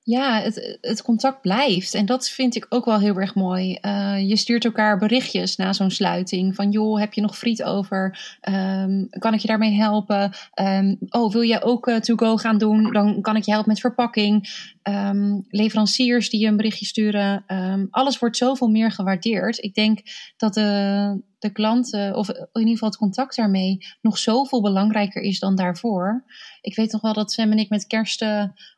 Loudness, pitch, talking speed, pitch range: -21 LUFS, 215 Hz, 200 wpm, 200-225 Hz